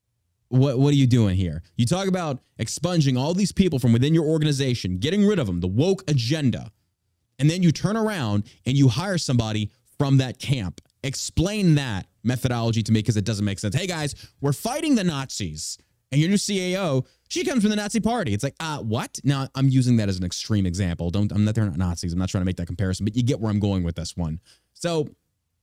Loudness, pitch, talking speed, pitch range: -23 LUFS, 125 Hz, 230 wpm, 100-150 Hz